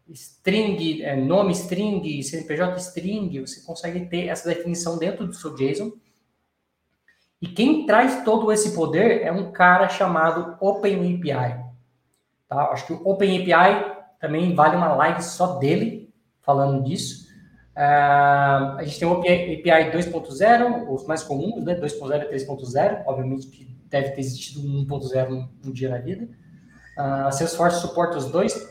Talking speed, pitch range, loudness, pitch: 145 wpm, 140-185 Hz, -22 LUFS, 165 Hz